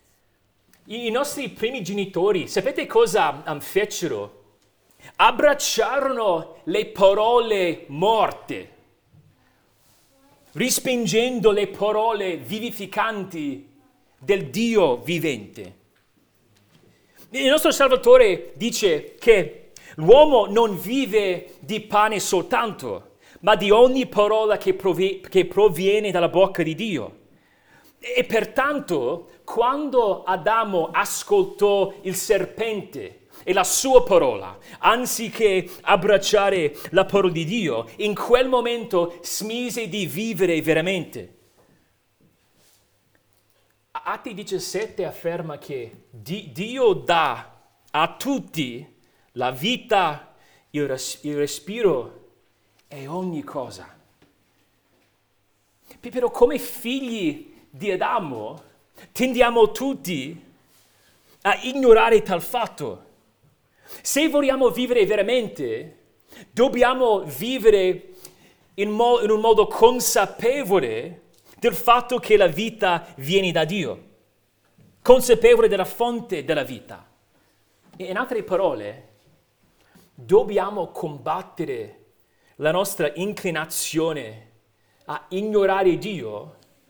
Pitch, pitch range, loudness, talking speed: 205 Hz, 170-245 Hz, -21 LUFS, 90 wpm